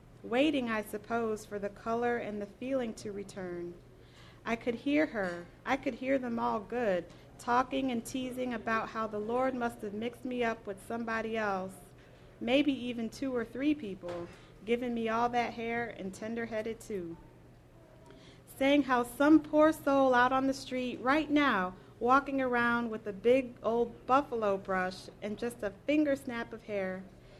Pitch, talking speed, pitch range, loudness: 235 Hz, 170 wpm, 205-255 Hz, -32 LUFS